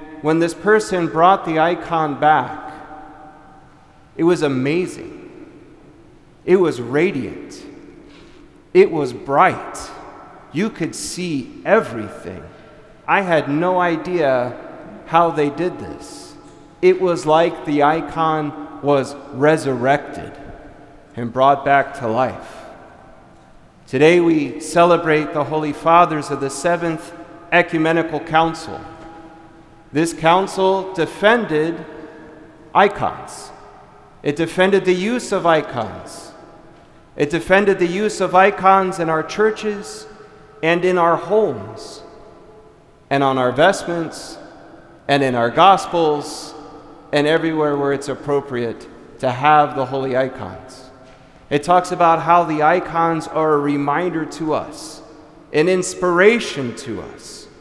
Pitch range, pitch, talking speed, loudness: 145-175 Hz, 160 Hz, 110 wpm, -17 LUFS